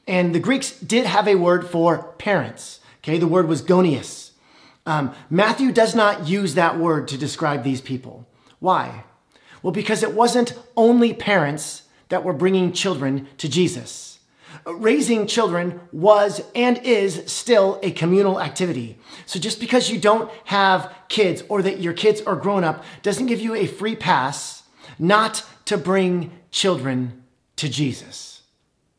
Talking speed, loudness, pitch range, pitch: 150 wpm, -20 LUFS, 155-215 Hz, 185 Hz